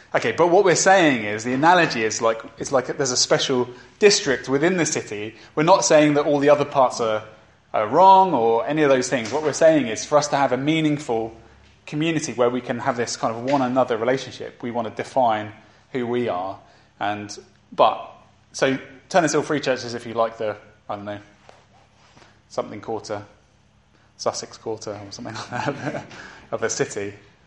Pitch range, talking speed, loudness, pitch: 110-145 Hz, 195 wpm, -20 LUFS, 125 Hz